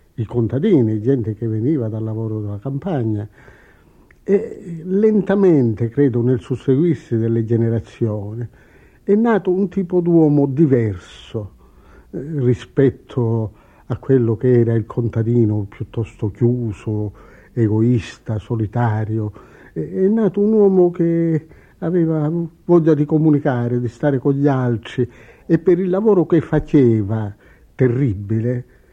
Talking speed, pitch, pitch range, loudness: 110 wpm, 125 Hz, 110-160 Hz, -18 LUFS